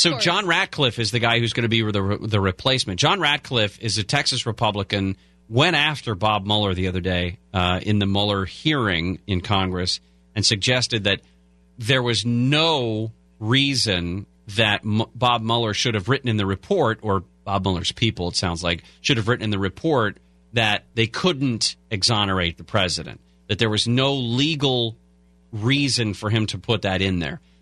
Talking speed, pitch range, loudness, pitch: 180 wpm, 95-120 Hz, -21 LUFS, 110 Hz